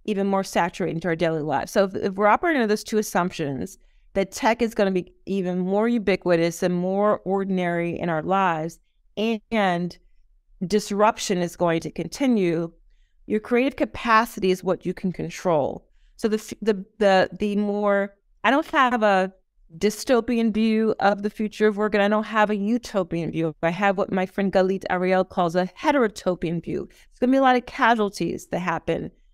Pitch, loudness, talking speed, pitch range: 195 Hz, -23 LUFS, 185 wpm, 180-215 Hz